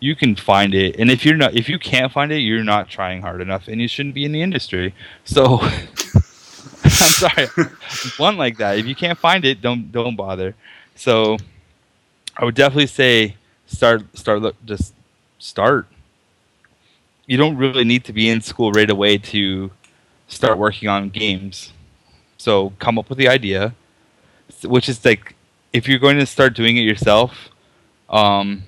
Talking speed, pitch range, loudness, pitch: 175 wpm, 100-130 Hz, -16 LUFS, 110 Hz